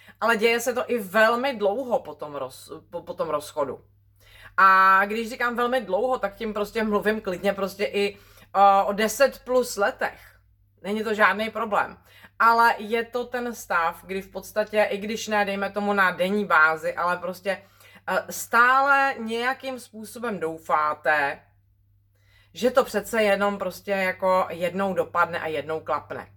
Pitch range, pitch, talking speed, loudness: 170-225 Hz, 200 Hz, 155 wpm, -23 LUFS